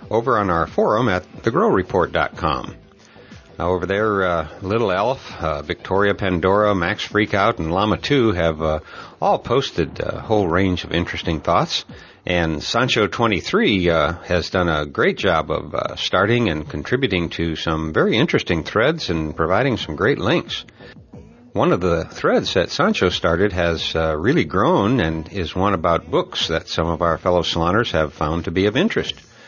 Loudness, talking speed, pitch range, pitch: -19 LUFS, 165 wpm, 80-100 Hz, 85 Hz